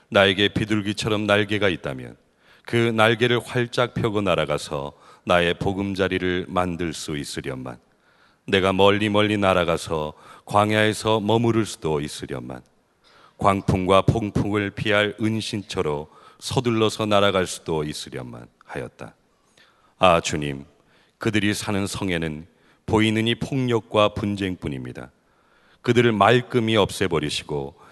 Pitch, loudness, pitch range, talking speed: 100 Hz, -22 LUFS, 85-110 Hz, 275 characters per minute